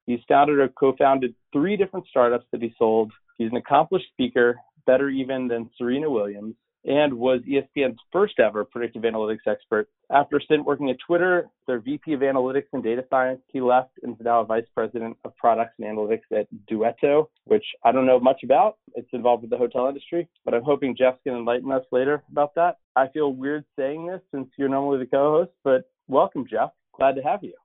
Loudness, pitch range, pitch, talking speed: -23 LUFS, 120-145 Hz, 130 Hz, 200 wpm